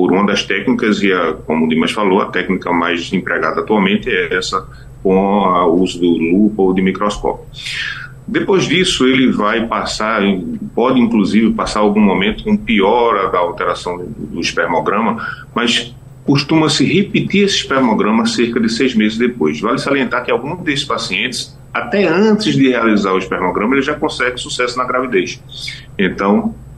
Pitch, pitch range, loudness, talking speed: 125 Hz, 95-140 Hz, -14 LUFS, 160 wpm